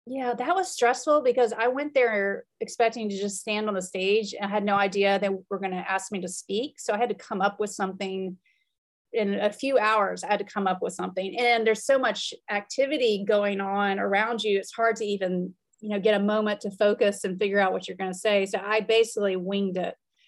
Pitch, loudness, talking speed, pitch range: 210 Hz, -26 LUFS, 230 wpm, 195-230 Hz